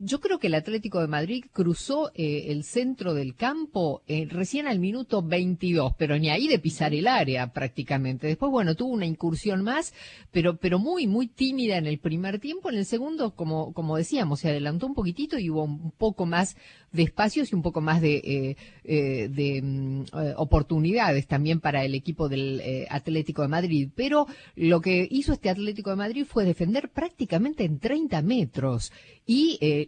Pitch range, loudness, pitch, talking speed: 150-225 Hz, -27 LUFS, 170 Hz, 185 wpm